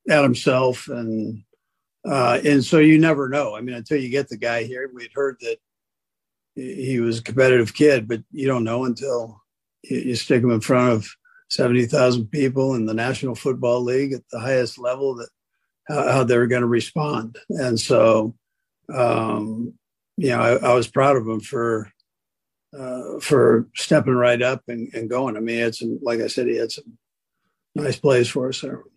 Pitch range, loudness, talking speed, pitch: 115-135 Hz, -20 LUFS, 190 wpm, 125 Hz